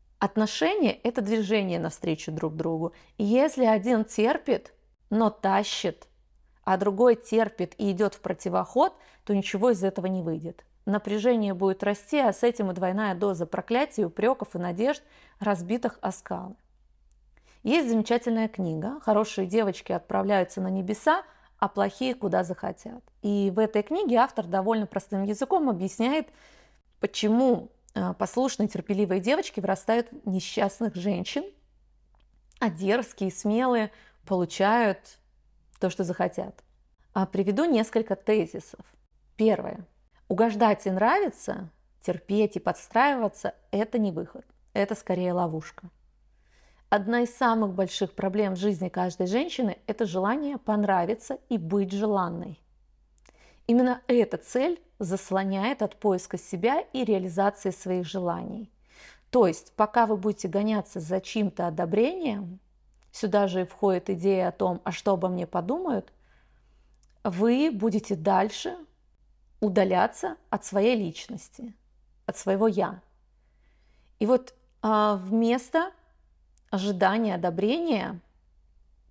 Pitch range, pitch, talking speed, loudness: 185-230 Hz, 205 Hz, 120 wpm, -27 LUFS